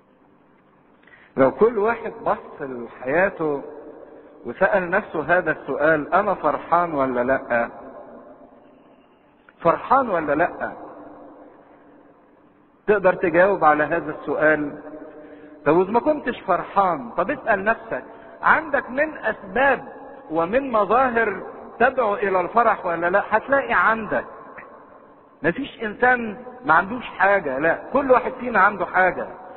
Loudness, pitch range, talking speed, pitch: -21 LUFS, 165-245 Hz, 105 wpm, 205 Hz